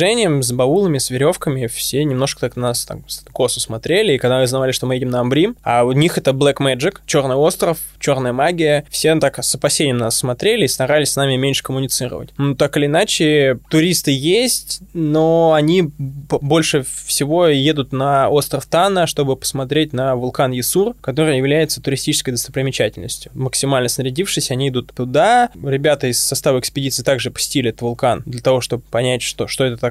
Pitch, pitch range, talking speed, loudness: 135 Hz, 130-150 Hz, 175 wpm, -16 LUFS